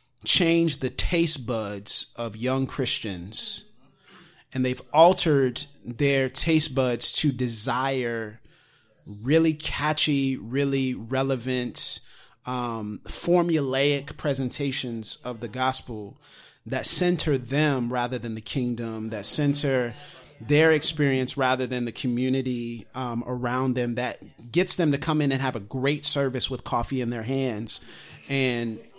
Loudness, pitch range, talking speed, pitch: -24 LUFS, 120-140 Hz, 125 wpm, 130 Hz